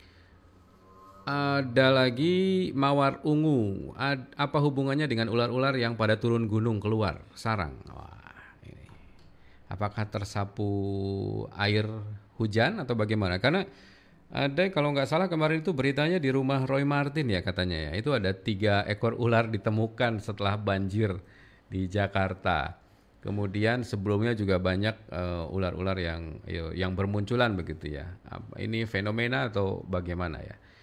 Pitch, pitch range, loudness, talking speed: 110 Hz, 95-130 Hz, -28 LUFS, 125 wpm